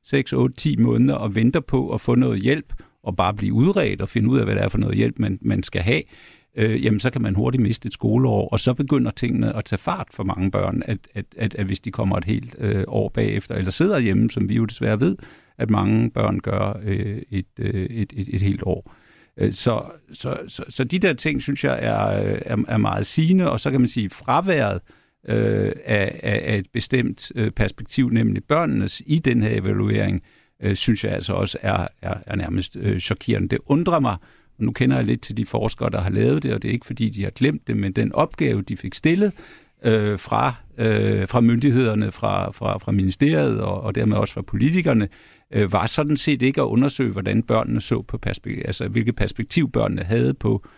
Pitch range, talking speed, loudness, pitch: 100-125 Hz, 215 wpm, -22 LUFS, 110 Hz